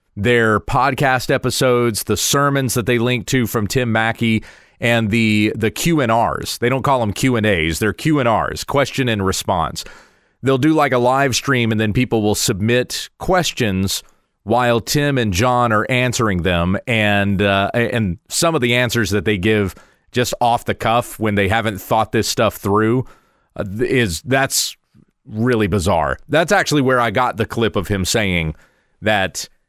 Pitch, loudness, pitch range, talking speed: 115 Hz, -17 LUFS, 105-125 Hz, 165 wpm